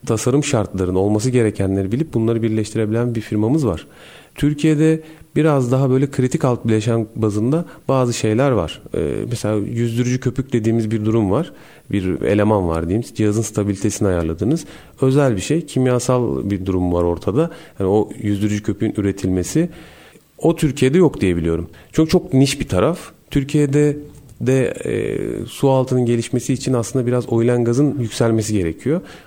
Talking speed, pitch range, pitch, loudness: 145 wpm, 105-145 Hz, 120 Hz, -18 LUFS